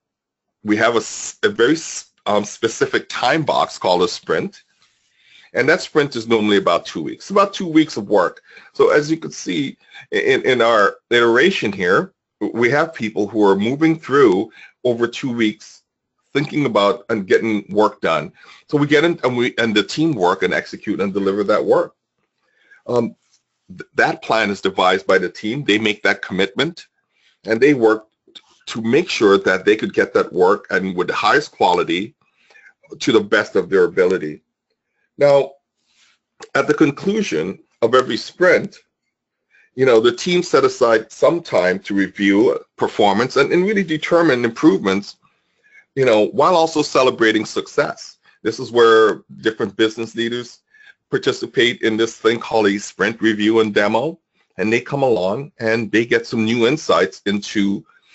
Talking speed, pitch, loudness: 165 wpm, 125 Hz, -17 LUFS